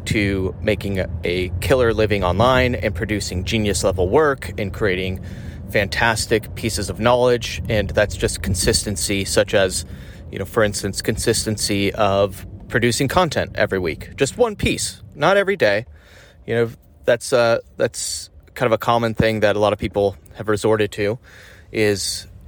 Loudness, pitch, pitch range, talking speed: -19 LUFS, 105 Hz, 95-115 Hz, 155 wpm